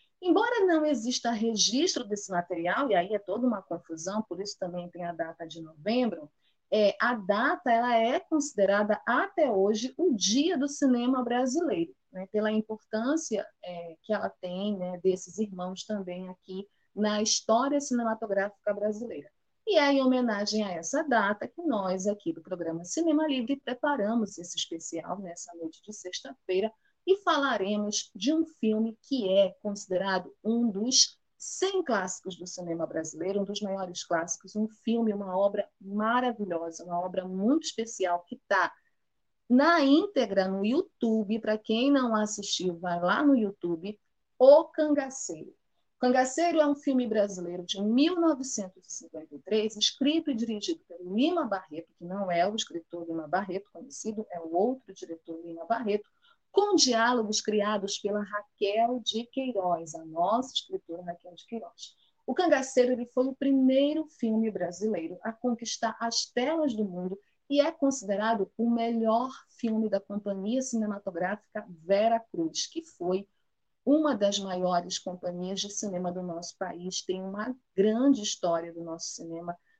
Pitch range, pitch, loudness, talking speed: 185-255 Hz, 215 Hz, -29 LUFS, 150 wpm